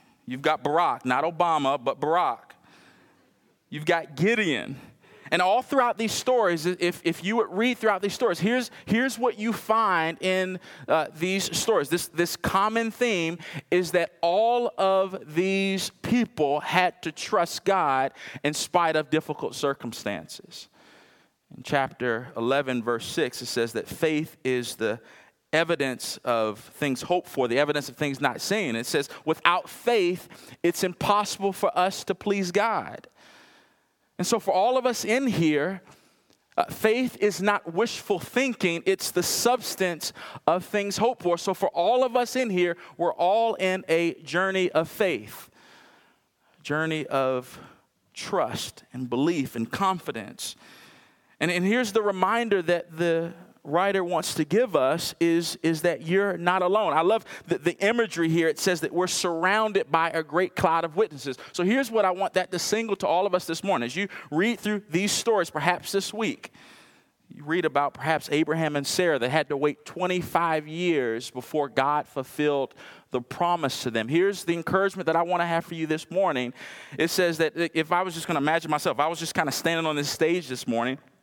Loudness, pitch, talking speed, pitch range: -25 LUFS, 175 Hz, 175 wpm, 155-195 Hz